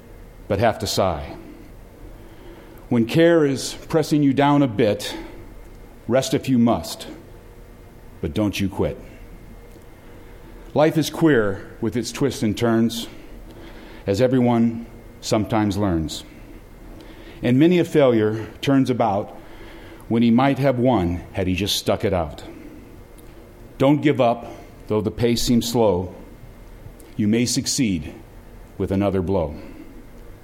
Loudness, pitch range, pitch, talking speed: -20 LUFS, 105-125 Hz, 115 Hz, 125 wpm